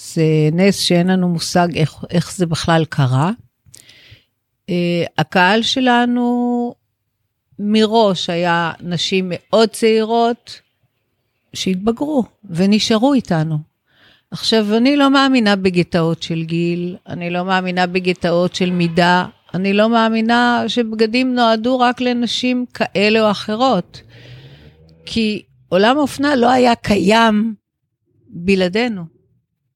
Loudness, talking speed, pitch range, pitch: -16 LUFS, 105 wpm, 160-225 Hz, 185 Hz